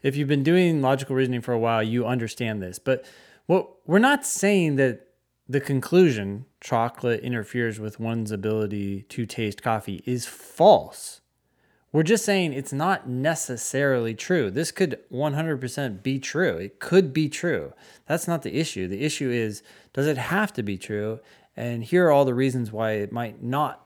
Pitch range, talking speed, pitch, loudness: 115-155 Hz, 175 wpm, 130 Hz, -24 LUFS